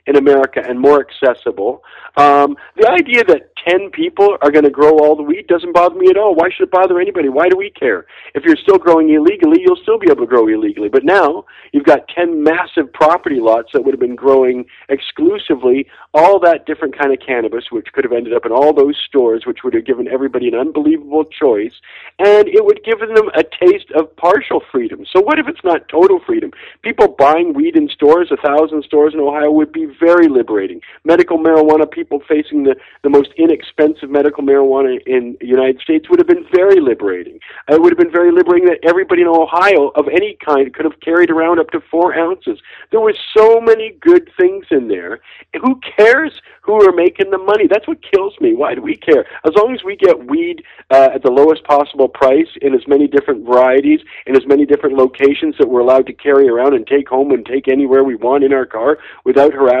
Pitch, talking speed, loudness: 180 Hz, 215 wpm, -12 LUFS